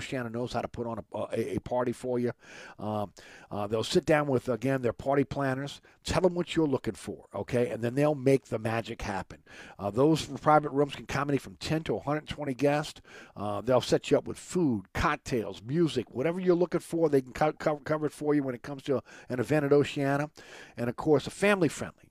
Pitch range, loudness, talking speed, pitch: 120-150 Hz, -29 LUFS, 225 wpm, 135 Hz